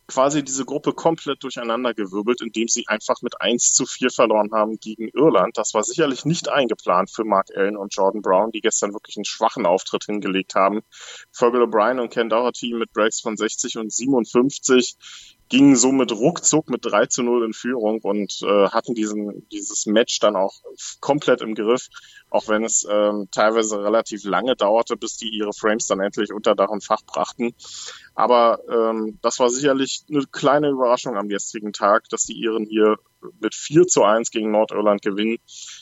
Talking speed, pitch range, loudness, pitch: 185 wpm, 105-130 Hz, -20 LUFS, 115 Hz